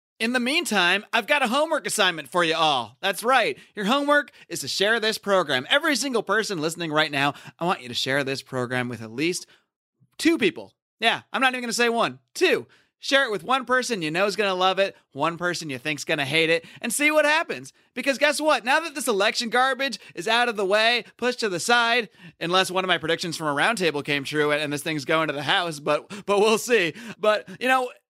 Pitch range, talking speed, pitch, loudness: 160-255 Hz, 235 wpm, 200 Hz, -23 LUFS